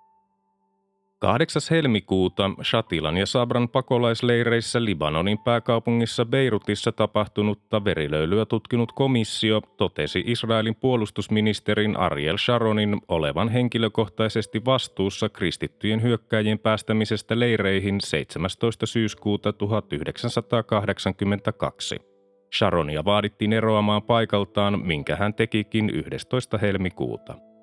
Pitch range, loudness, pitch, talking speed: 100-115 Hz, -24 LUFS, 110 Hz, 80 wpm